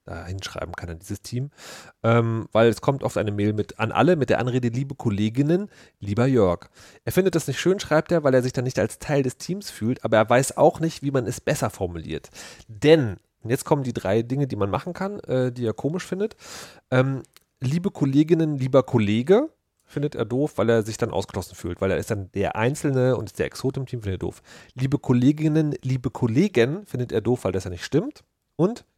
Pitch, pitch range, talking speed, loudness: 125 Hz, 110-145 Hz, 220 wpm, -23 LUFS